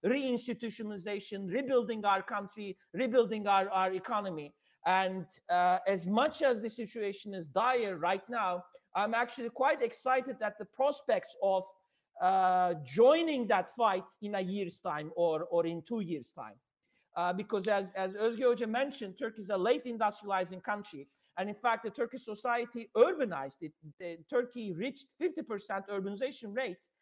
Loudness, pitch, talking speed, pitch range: -33 LUFS, 210 Hz, 150 wpm, 185-240 Hz